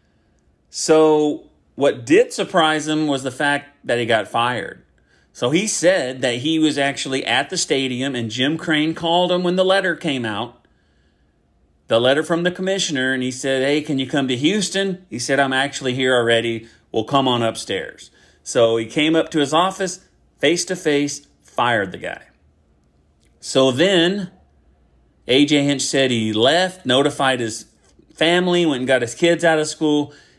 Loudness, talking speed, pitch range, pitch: -18 LUFS, 170 wpm, 115-160 Hz, 140 Hz